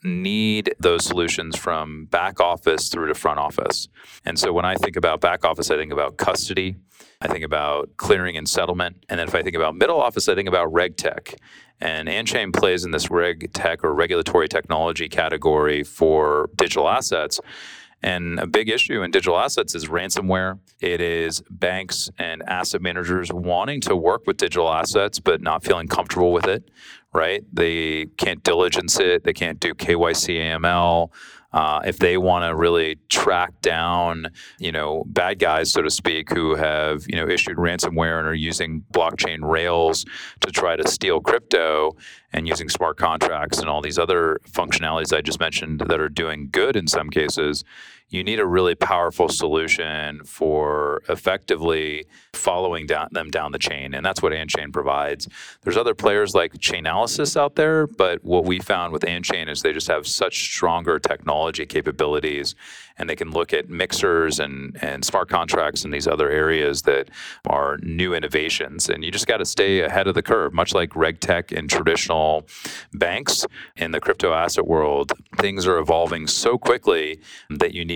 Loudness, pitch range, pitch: -21 LUFS, 80-95 Hz, 85 Hz